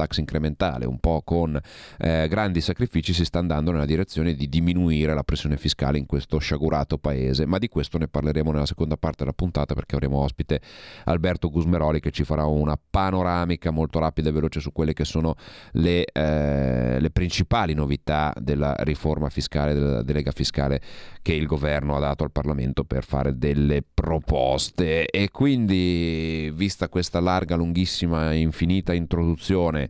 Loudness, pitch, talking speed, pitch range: -24 LUFS, 80 Hz, 160 wpm, 75-85 Hz